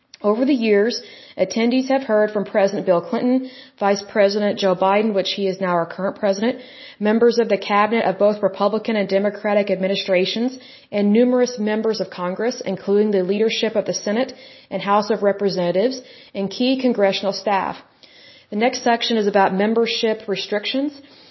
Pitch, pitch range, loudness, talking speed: 210 Hz, 195-235 Hz, -19 LUFS, 160 wpm